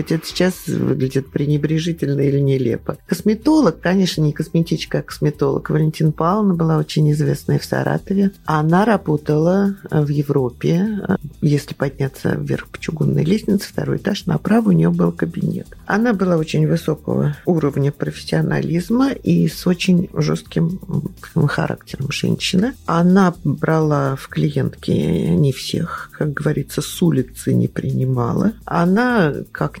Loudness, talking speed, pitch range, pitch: -18 LUFS, 125 wpm, 145-185 Hz, 160 Hz